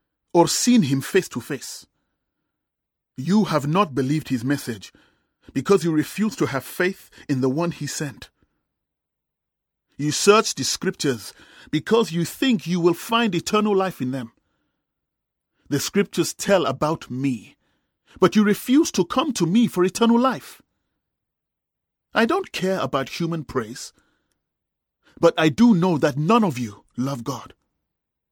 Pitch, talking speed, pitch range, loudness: 165 Hz, 145 wpm, 135-200 Hz, -21 LUFS